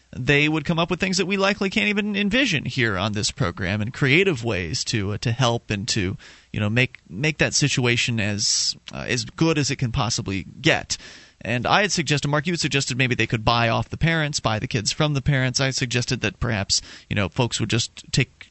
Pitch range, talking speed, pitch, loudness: 110-150 Hz, 230 wpm, 125 Hz, -22 LUFS